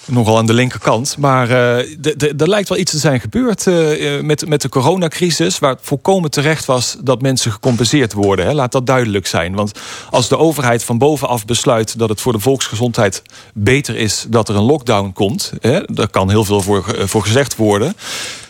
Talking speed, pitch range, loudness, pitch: 200 wpm, 110-150 Hz, -14 LUFS, 125 Hz